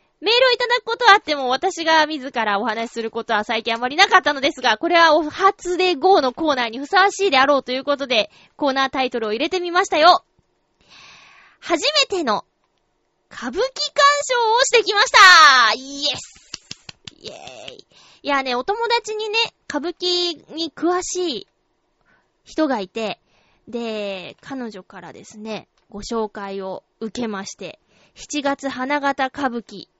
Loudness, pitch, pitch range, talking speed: -18 LUFS, 285 Hz, 235-360 Hz, 300 characters per minute